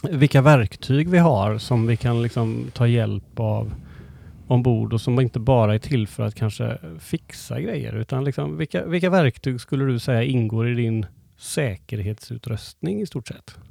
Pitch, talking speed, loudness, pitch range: 120 Hz, 170 wpm, -22 LUFS, 110-135 Hz